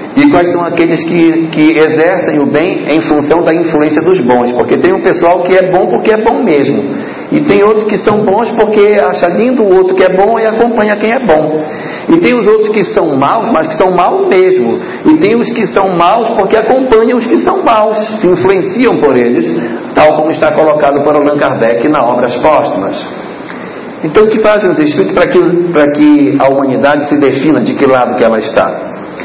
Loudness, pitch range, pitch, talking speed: -8 LUFS, 155-215 Hz, 180 Hz, 210 wpm